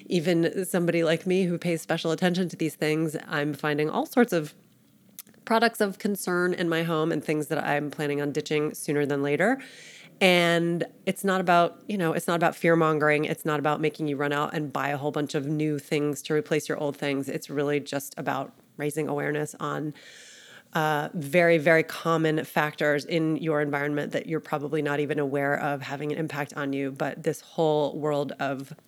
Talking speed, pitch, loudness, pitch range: 195 wpm, 155 Hz, -26 LUFS, 145-170 Hz